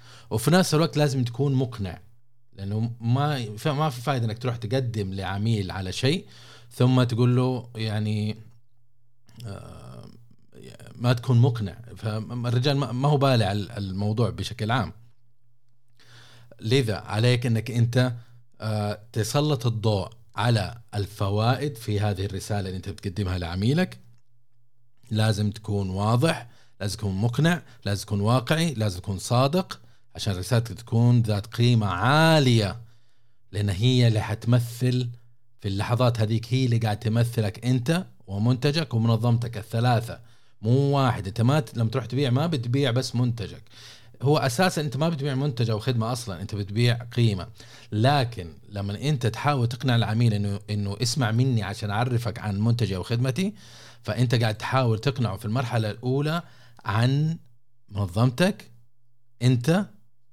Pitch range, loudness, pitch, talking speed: 110-125 Hz, -25 LUFS, 120 Hz, 125 wpm